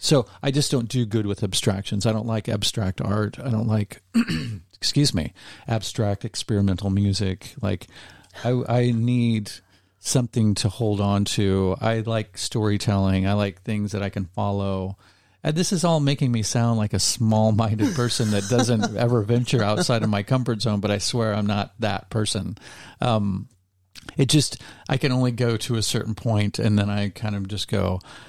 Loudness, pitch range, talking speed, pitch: -23 LUFS, 100-120 Hz, 180 wpm, 110 Hz